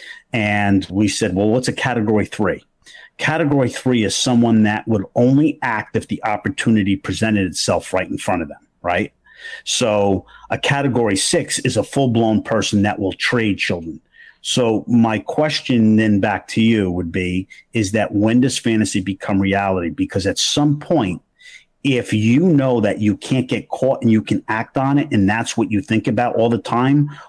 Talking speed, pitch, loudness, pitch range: 180 wpm, 110 Hz, -18 LUFS, 100-130 Hz